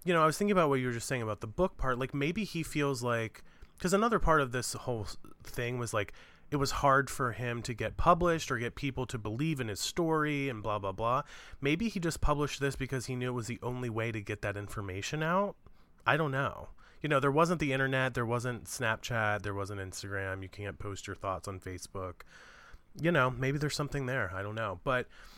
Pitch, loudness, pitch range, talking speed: 125 Hz, -33 LUFS, 105-145 Hz, 235 wpm